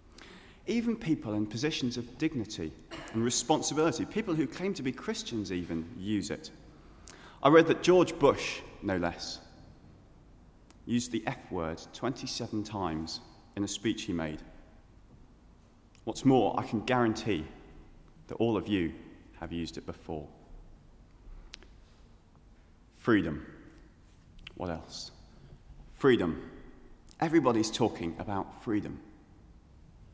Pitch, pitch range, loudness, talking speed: 110 Hz, 85-125 Hz, -31 LUFS, 110 wpm